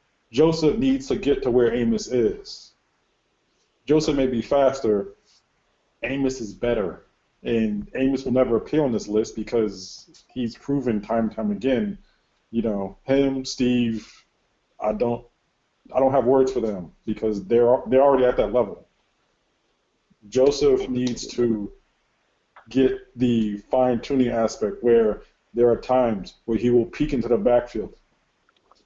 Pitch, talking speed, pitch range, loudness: 120 Hz, 140 wpm, 110-135 Hz, -22 LUFS